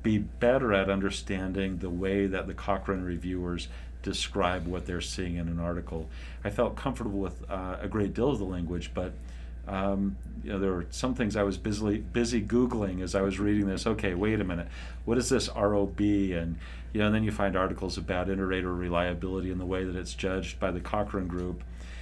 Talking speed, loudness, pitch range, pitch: 205 wpm, -30 LUFS, 85-100 Hz, 95 Hz